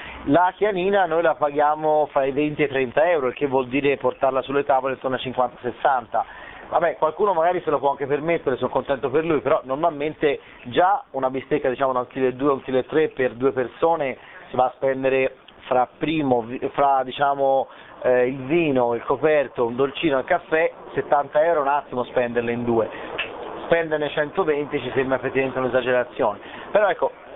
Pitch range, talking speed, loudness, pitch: 130-150 Hz, 180 wpm, -22 LUFS, 135 Hz